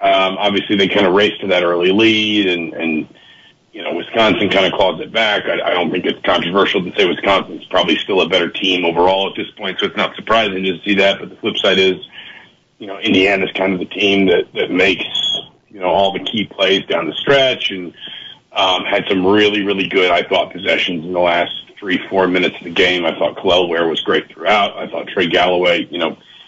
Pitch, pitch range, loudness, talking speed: 95 Hz, 90-100 Hz, -15 LUFS, 230 wpm